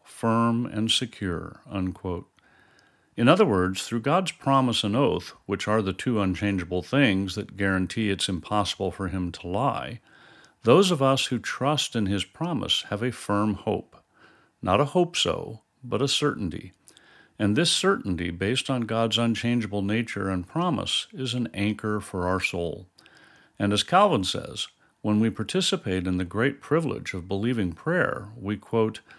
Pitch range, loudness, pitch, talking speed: 95-125 Hz, -25 LUFS, 105 Hz, 155 wpm